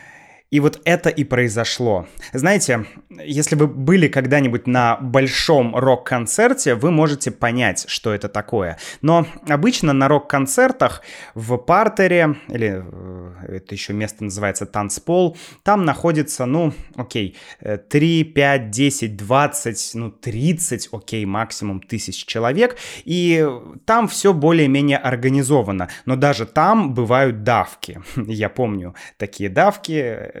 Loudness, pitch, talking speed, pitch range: -18 LUFS, 135 Hz, 115 wpm, 115-160 Hz